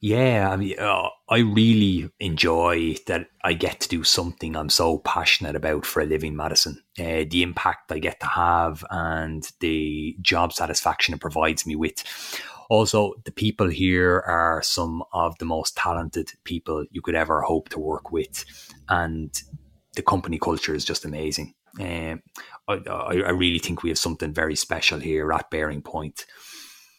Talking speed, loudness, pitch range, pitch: 165 wpm, -23 LUFS, 80-90 Hz, 85 Hz